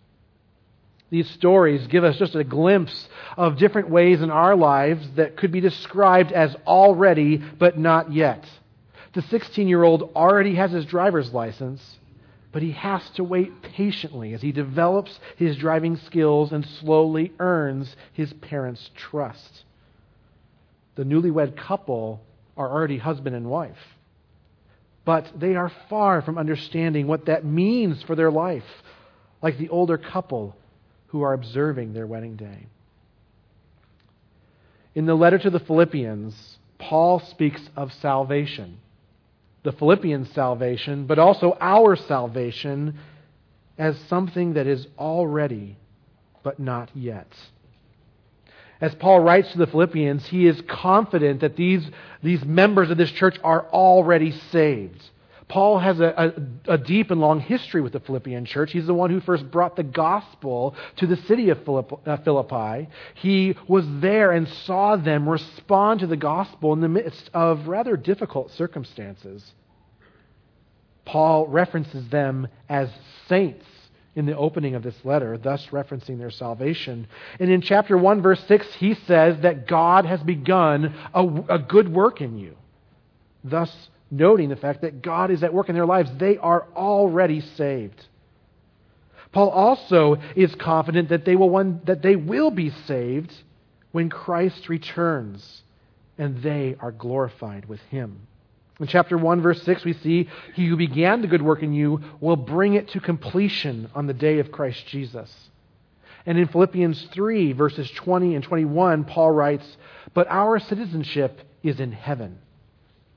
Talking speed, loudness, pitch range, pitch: 150 wpm, -21 LUFS, 135-175 Hz, 155 Hz